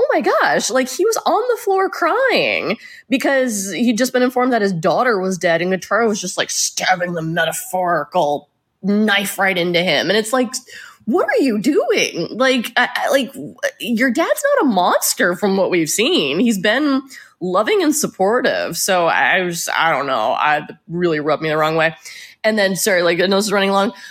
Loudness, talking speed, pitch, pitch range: -17 LUFS, 195 wpm, 205 Hz, 180-265 Hz